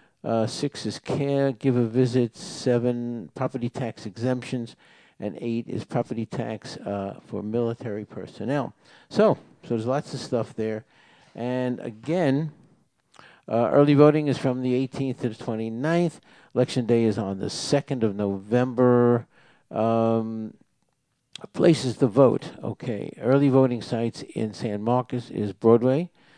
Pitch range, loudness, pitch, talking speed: 115-135 Hz, -25 LUFS, 125 Hz, 135 wpm